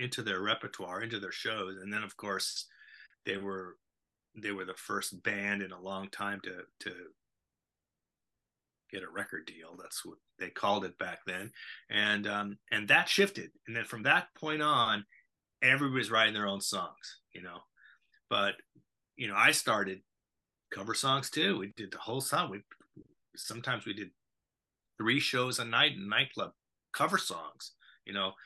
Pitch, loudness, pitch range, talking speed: 105 Hz, -32 LUFS, 100-130 Hz, 165 wpm